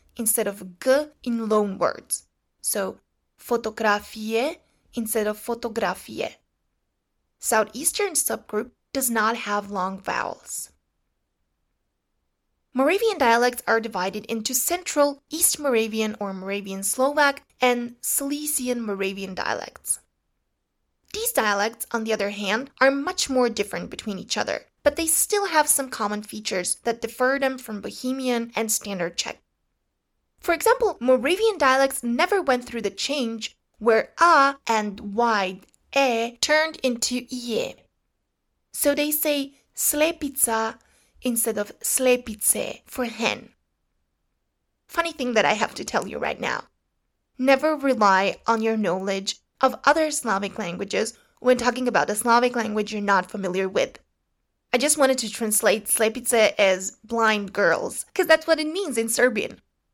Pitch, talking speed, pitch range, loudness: 240 Hz, 130 wpm, 215-275 Hz, -23 LUFS